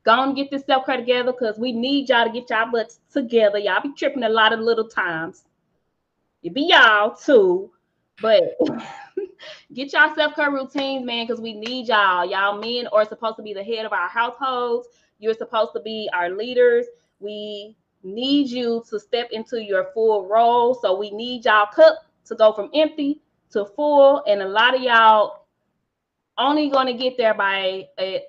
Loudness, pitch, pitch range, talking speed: -19 LUFS, 235 Hz, 215-275 Hz, 190 wpm